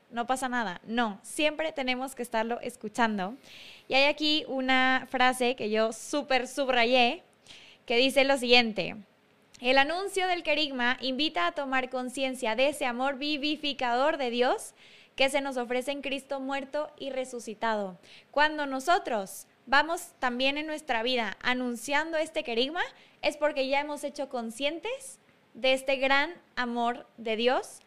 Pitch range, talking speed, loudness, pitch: 240-290 Hz, 145 wpm, -28 LUFS, 265 Hz